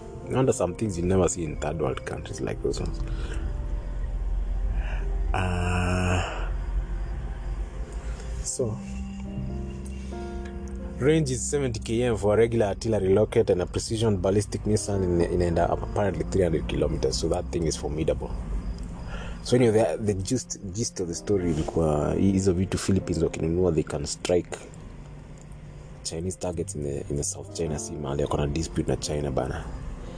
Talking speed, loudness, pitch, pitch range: 120 wpm, -27 LUFS, 85 Hz, 70-95 Hz